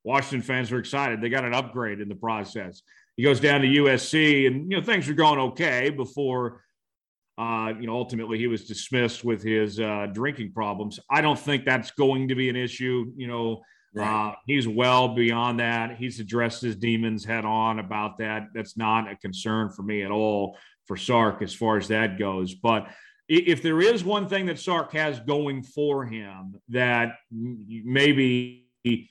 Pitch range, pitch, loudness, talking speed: 110-135 Hz, 120 Hz, -25 LUFS, 185 wpm